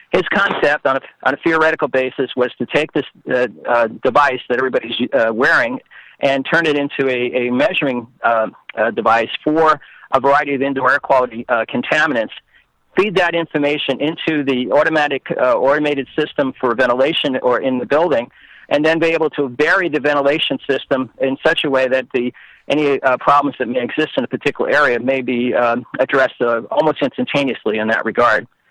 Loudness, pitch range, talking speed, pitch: -16 LUFS, 130-150 Hz, 185 wpm, 140 Hz